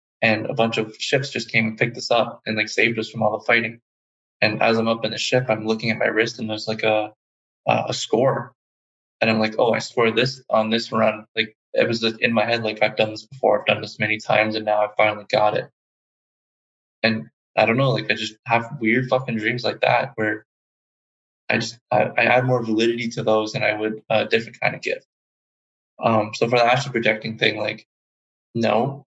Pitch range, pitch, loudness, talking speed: 105-115 Hz, 110 Hz, -21 LUFS, 230 wpm